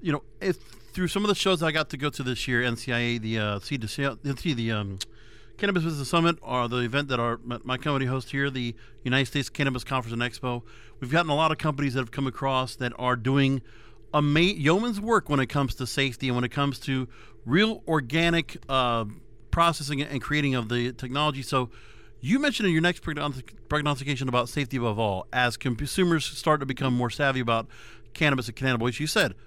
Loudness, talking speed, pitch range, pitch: -26 LUFS, 210 wpm, 120-150 Hz, 135 Hz